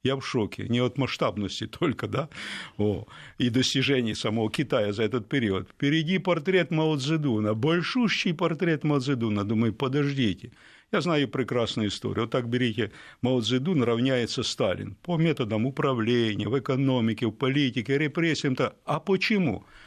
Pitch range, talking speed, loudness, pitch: 115-150 Hz, 140 wpm, -26 LUFS, 130 Hz